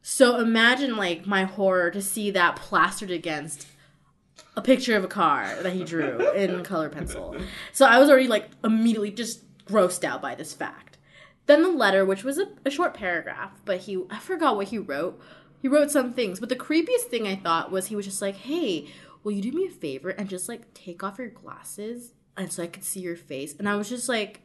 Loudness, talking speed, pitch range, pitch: -24 LUFS, 220 wpm, 185-250 Hz, 205 Hz